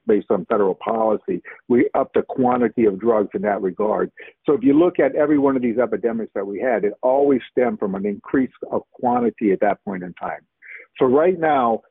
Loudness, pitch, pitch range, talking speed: -20 LUFS, 130 Hz, 115-150 Hz, 210 wpm